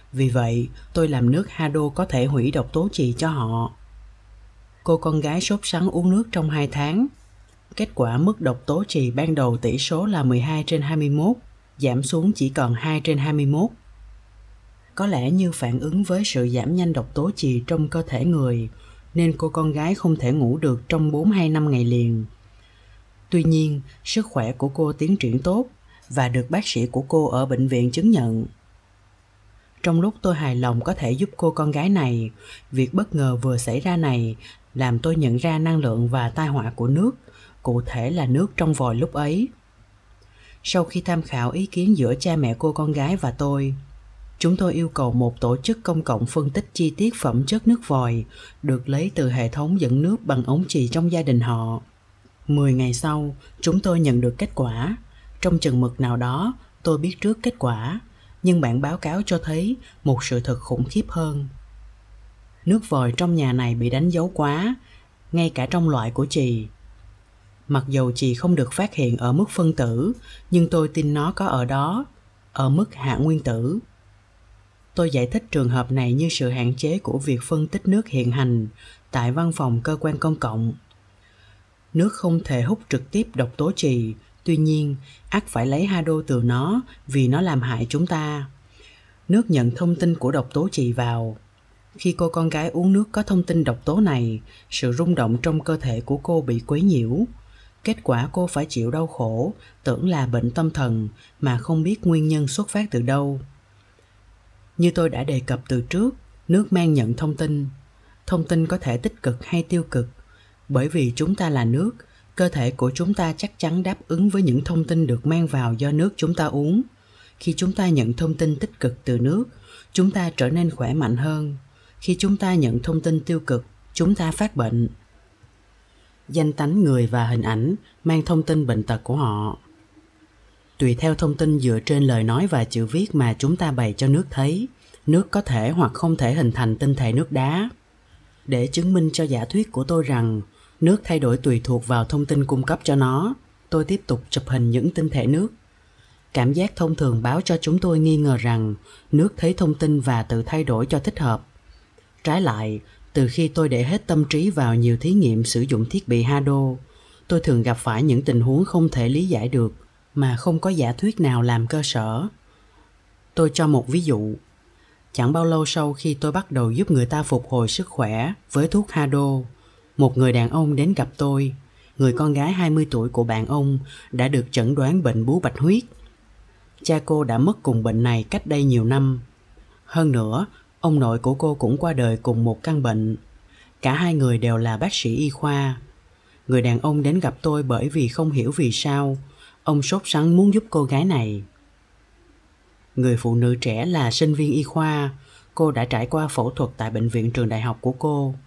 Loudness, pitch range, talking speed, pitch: -22 LUFS, 120-165 Hz, 205 wpm, 135 Hz